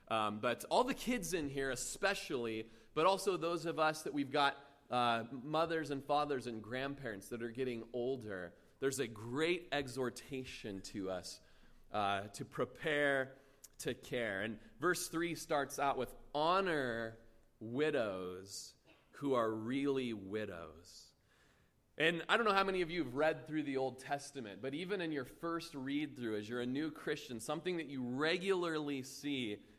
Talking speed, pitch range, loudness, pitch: 160 wpm, 115-155 Hz, -38 LUFS, 135 Hz